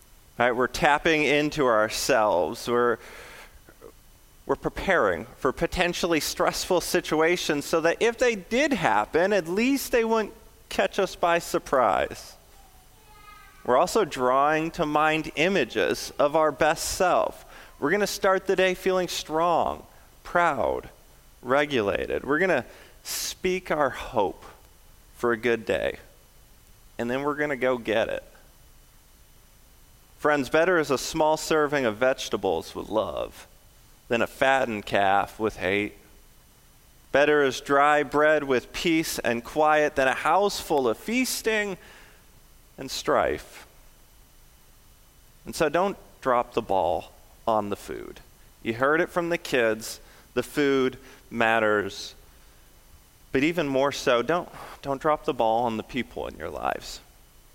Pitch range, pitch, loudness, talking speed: 130-180 Hz, 155 Hz, -25 LUFS, 135 wpm